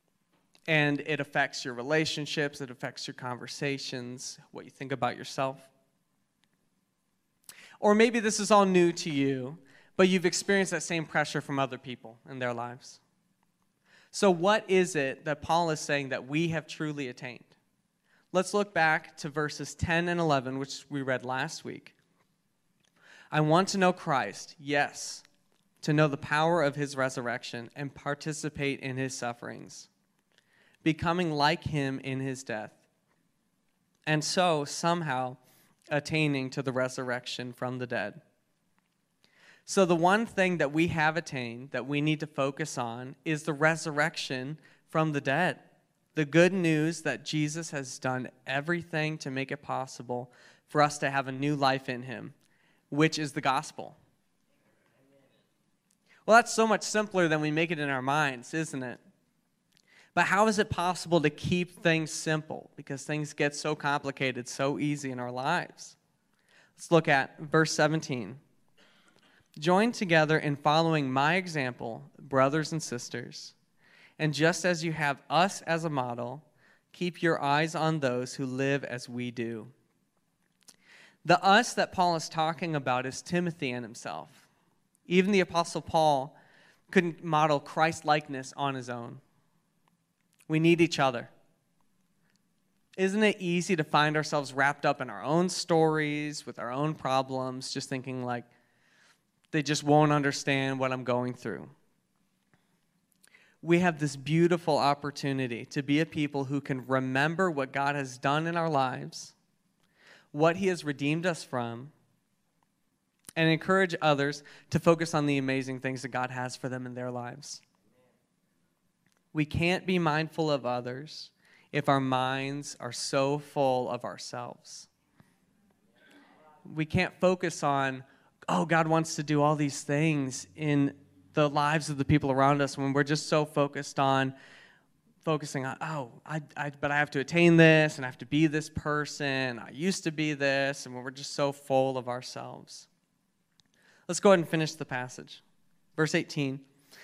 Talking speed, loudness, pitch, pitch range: 155 wpm, -29 LUFS, 150 Hz, 135-165 Hz